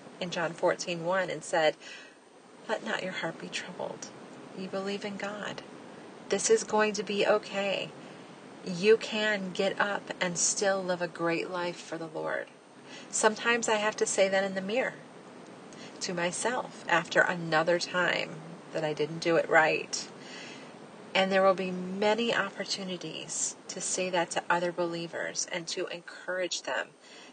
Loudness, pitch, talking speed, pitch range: -30 LUFS, 190 Hz, 155 wpm, 175-210 Hz